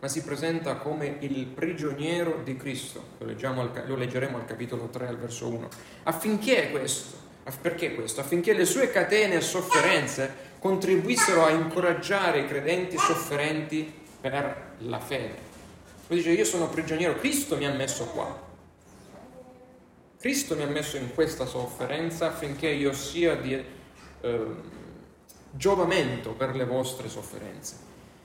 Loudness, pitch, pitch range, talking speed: -27 LUFS, 145 Hz, 130-165 Hz, 135 wpm